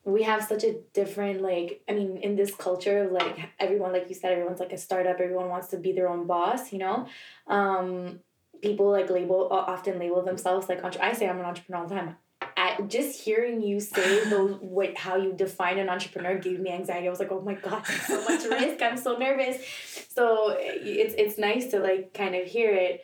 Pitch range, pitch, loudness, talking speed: 180-205 Hz, 190 Hz, -28 LUFS, 220 wpm